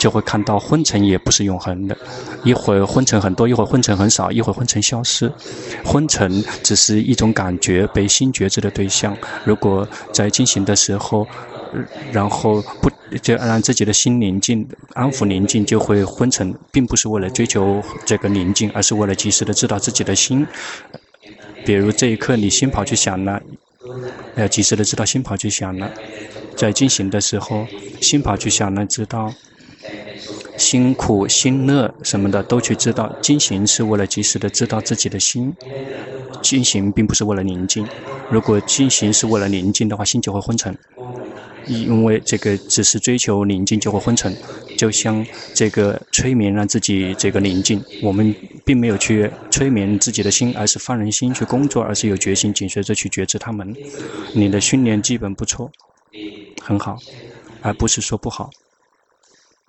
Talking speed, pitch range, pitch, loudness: 260 characters per minute, 100-120 Hz, 105 Hz, -17 LUFS